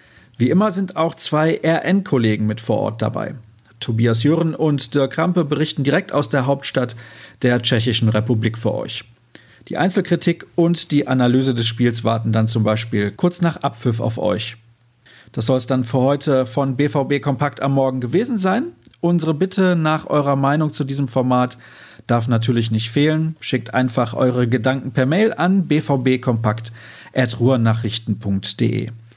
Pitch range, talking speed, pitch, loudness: 115-150 Hz, 150 wpm, 130 Hz, -19 LUFS